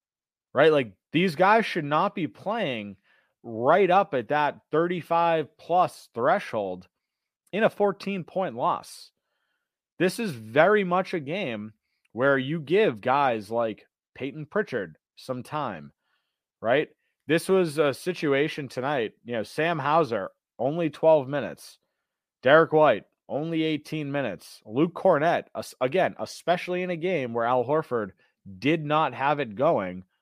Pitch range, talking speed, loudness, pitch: 130-180 Hz, 135 wpm, -25 LUFS, 155 Hz